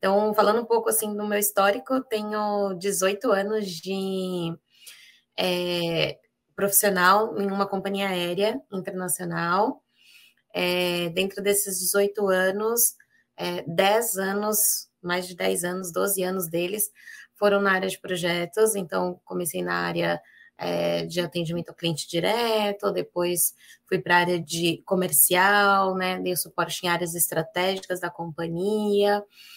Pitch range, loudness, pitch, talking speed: 175-205 Hz, -24 LUFS, 190 Hz, 130 wpm